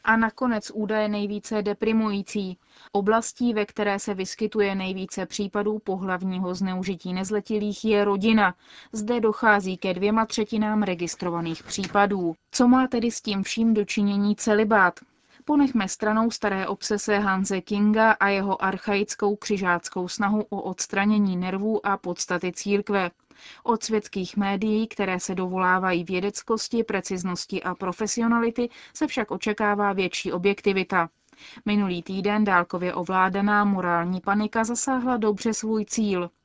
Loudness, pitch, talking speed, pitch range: -24 LUFS, 205 Hz, 120 wpm, 190-220 Hz